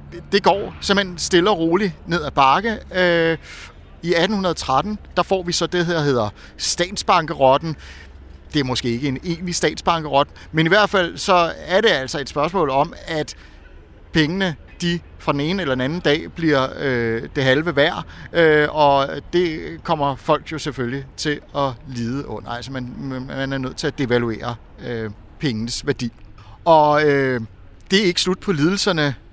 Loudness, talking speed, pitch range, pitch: -19 LUFS, 170 wpm, 125-170 Hz, 145 Hz